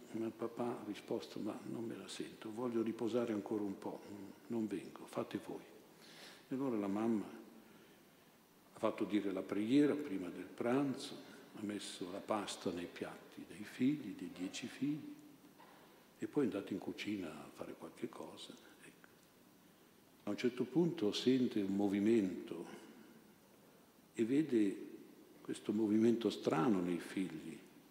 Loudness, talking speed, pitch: -40 LUFS, 145 wpm, 120 Hz